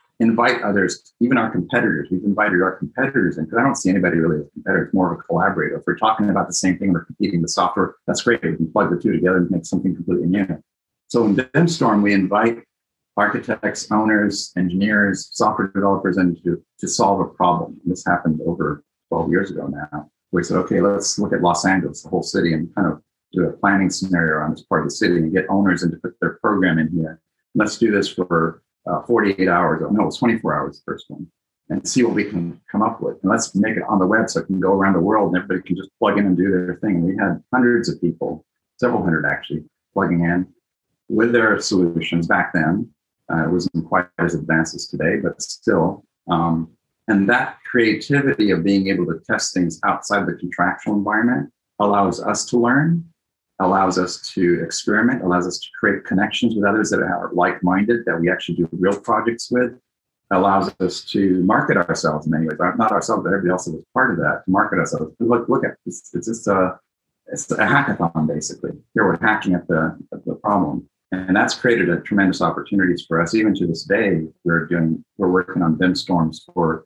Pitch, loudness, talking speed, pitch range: 95 Hz, -19 LUFS, 210 wpm, 85-105 Hz